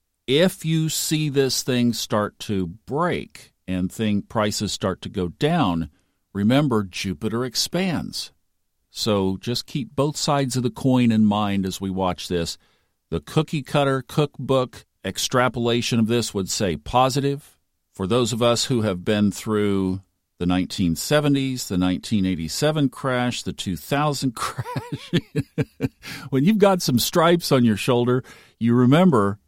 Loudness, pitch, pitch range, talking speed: -22 LUFS, 115 Hz, 95-135 Hz, 140 wpm